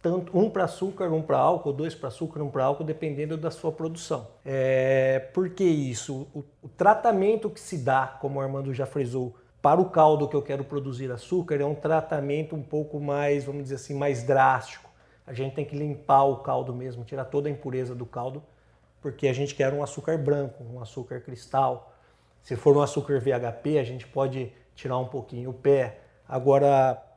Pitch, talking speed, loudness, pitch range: 140 Hz, 190 wpm, -26 LUFS, 130-150 Hz